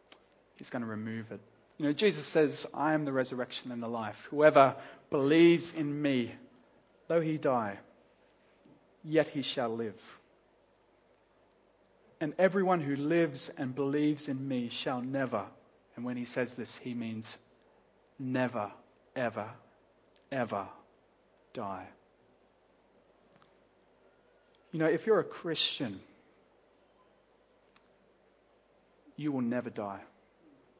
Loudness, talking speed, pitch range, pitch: -32 LUFS, 115 wpm, 115-150 Hz, 130 Hz